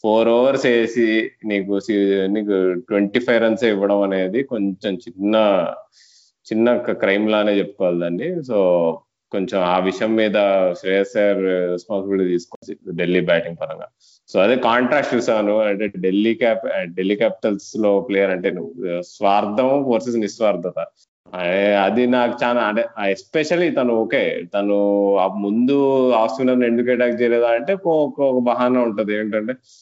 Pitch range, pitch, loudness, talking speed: 100-120 Hz, 105 Hz, -19 LUFS, 125 wpm